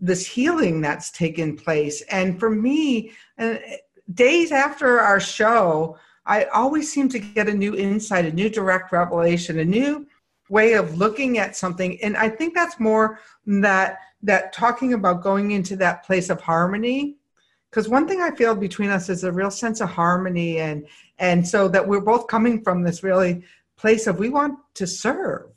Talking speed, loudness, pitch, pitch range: 175 wpm, -21 LUFS, 200 Hz, 185-230 Hz